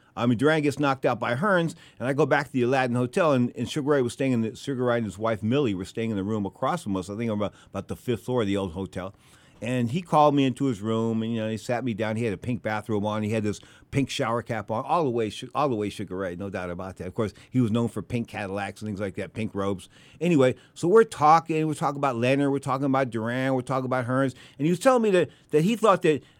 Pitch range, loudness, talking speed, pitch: 105-140 Hz, -26 LUFS, 290 wpm, 120 Hz